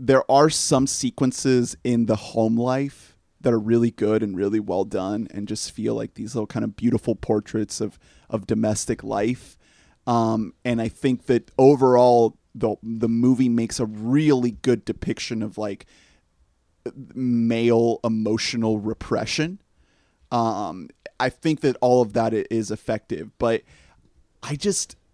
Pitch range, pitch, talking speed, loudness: 105-125 Hz, 115 Hz, 145 wpm, -22 LUFS